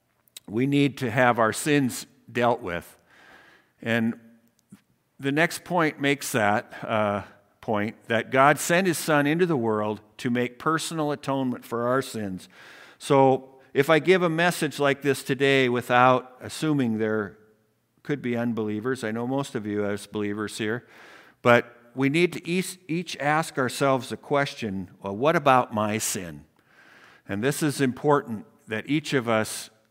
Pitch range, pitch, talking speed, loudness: 110-145 Hz, 125 Hz, 150 wpm, -25 LUFS